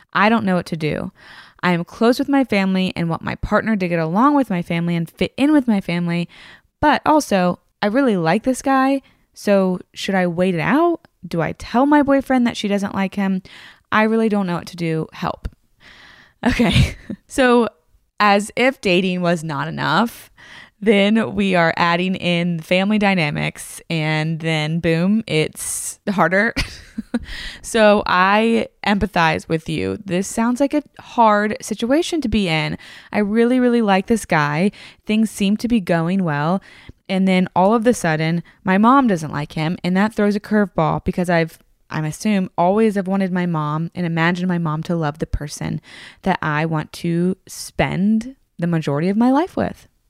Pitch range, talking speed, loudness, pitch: 170-220 Hz, 180 wpm, -18 LUFS, 190 Hz